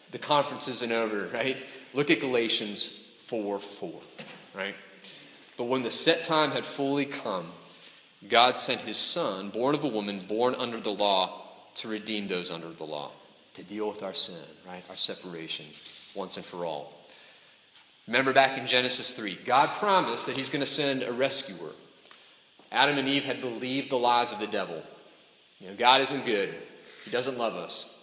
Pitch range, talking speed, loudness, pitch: 105-140 Hz, 175 wpm, -28 LUFS, 125 Hz